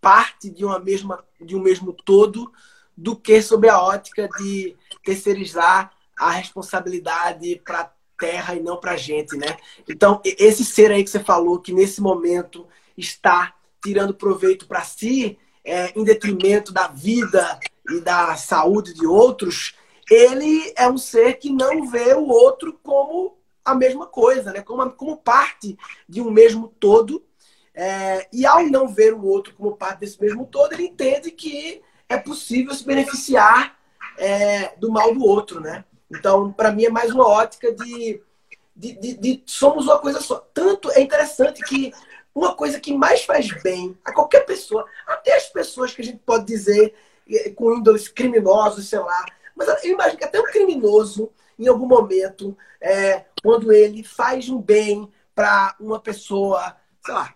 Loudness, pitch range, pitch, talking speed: -18 LUFS, 195-265 Hz, 220 Hz, 165 wpm